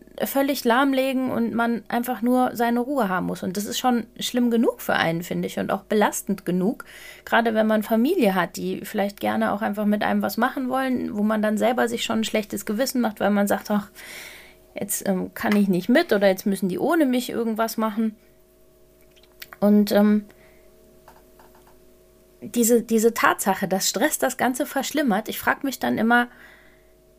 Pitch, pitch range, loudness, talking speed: 225 Hz, 205-245 Hz, -22 LUFS, 180 wpm